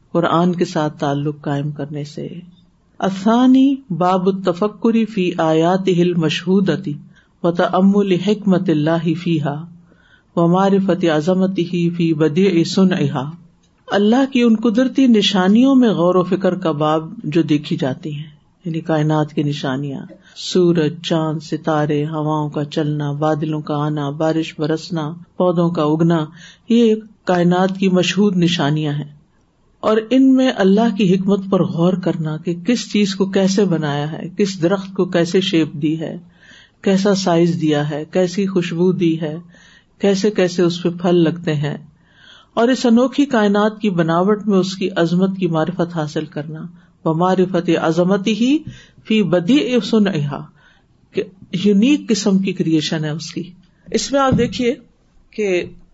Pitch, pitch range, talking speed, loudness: 175 Hz, 160-195 Hz, 145 wpm, -17 LUFS